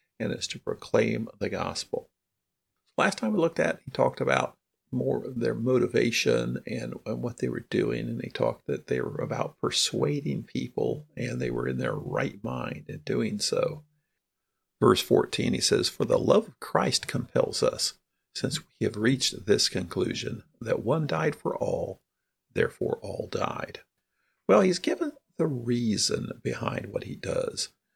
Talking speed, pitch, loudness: 165 wpm, 180 Hz, -28 LUFS